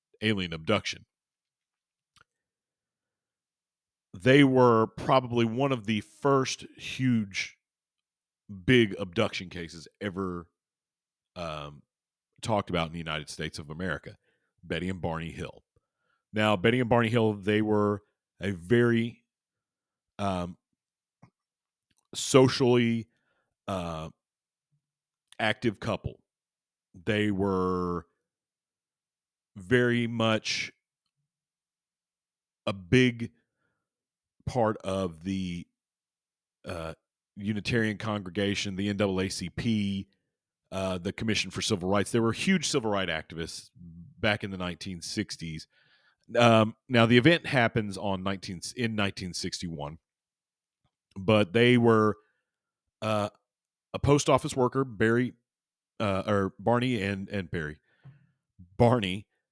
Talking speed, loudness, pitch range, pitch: 100 wpm, -28 LUFS, 95-120 Hz, 105 Hz